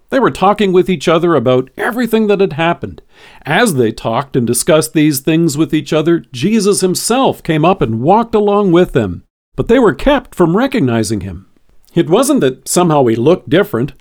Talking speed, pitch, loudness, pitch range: 190 wpm, 165 Hz, -12 LUFS, 130-195 Hz